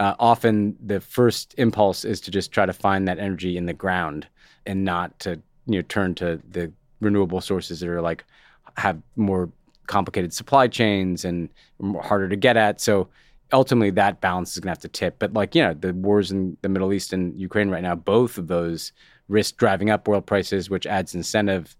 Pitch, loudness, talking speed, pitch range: 95 Hz, -23 LUFS, 205 wpm, 90-105 Hz